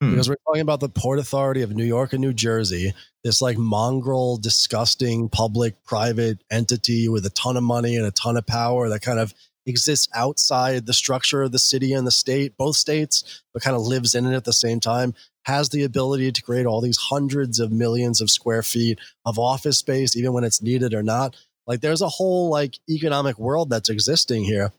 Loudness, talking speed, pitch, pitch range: -21 LUFS, 210 wpm, 125 Hz, 115-135 Hz